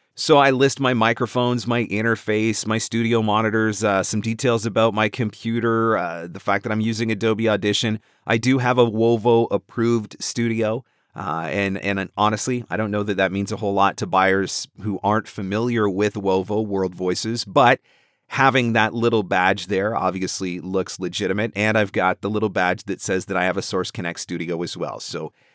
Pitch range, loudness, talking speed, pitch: 95-115 Hz, -21 LUFS, 190 wpm, 110 Hz